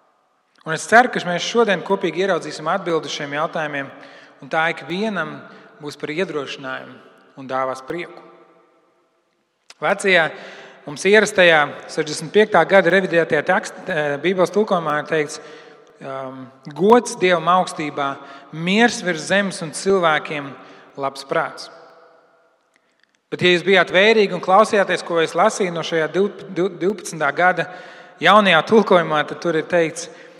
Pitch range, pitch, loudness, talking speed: 150-190 Hz, 170 Hz, -18 LUFS, 120 wpm